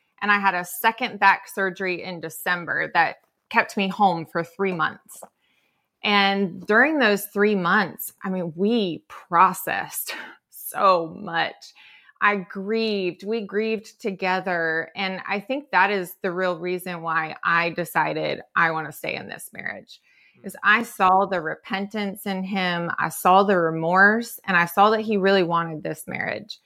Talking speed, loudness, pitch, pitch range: 160 wpm, -22 LUFS, 195 Hz, 180-205 Hz